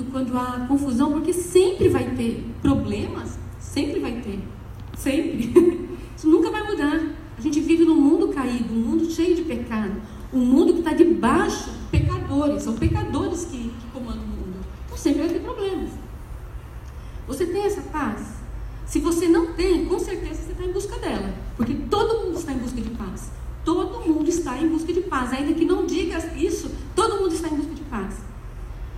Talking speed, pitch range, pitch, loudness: 180 wpm, 290-355 Hz, 330 Hz, -23 LUFS